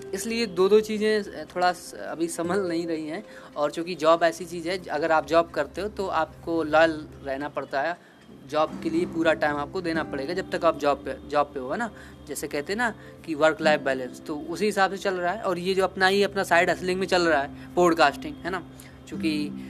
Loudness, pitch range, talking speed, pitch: -25 LUFS, 150-185 Hz, 230 wpm, 165 Hz